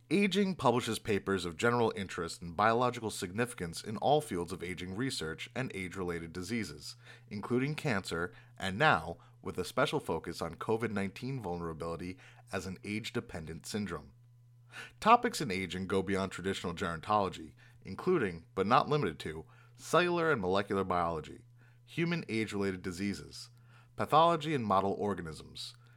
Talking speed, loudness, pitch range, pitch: 130 wpm, -33 LUFS, 90-120 Hz, 105 Hz